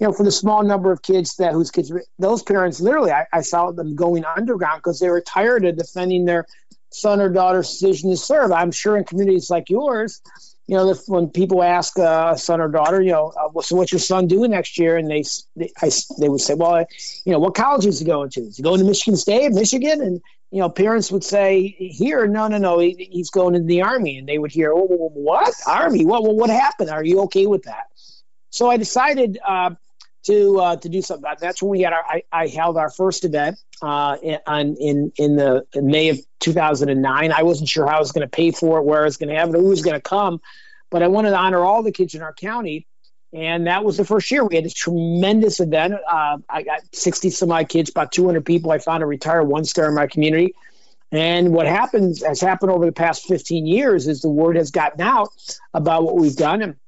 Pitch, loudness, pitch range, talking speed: 175 Hz, -18 LUFS, 160-190 Hz, 245 wpm